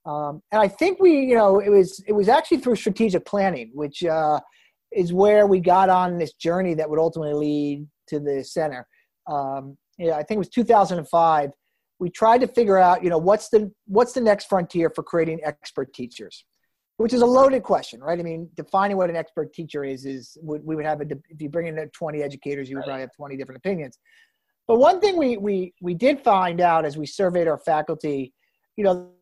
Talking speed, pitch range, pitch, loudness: 220 wpm, 150-205 Hz, 170 Hz, -21 LUFS